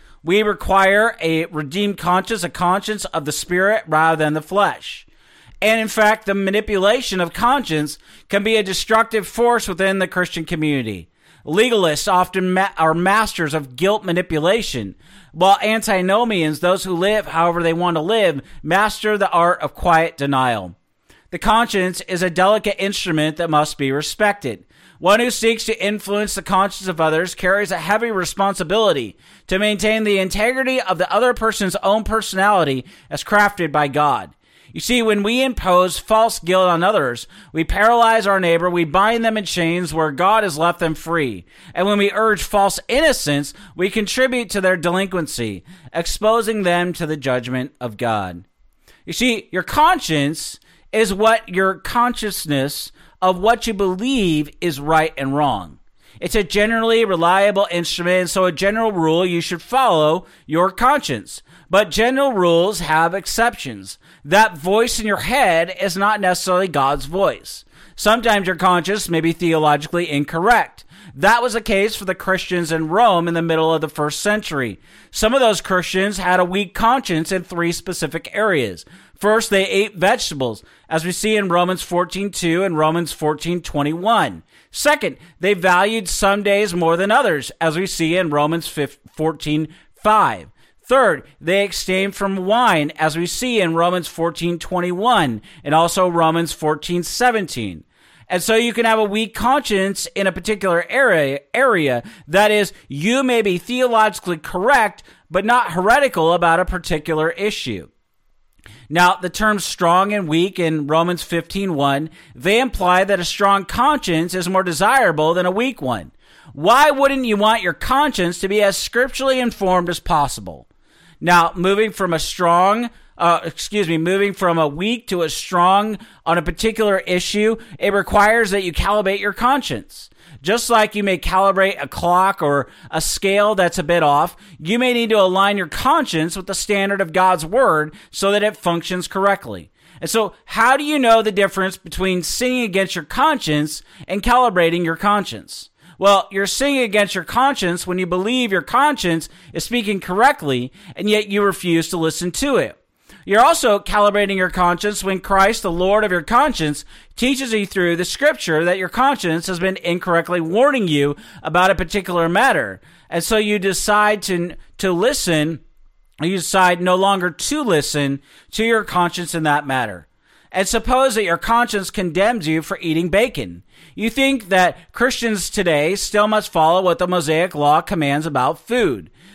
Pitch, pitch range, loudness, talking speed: 185 Hz, 165-210 Hz, -17 LUFS, 165 wpm